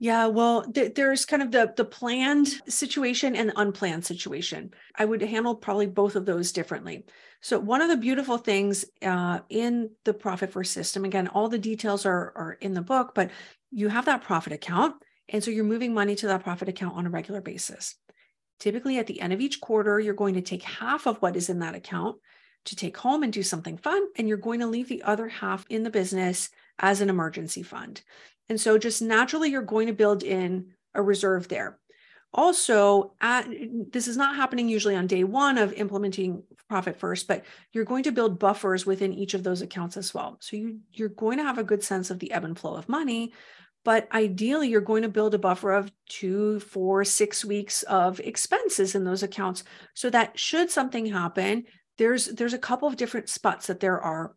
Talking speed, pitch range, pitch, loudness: 210 wpm, 195-235 Hz, 210 Hz, -26 LUFS